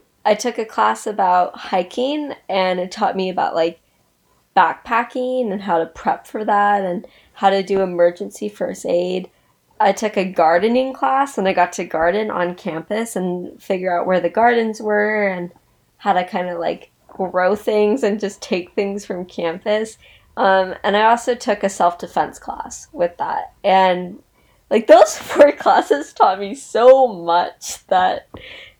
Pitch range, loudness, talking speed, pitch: 180-225 Hz, -18 LUFS, 165 wpm, 195 Hz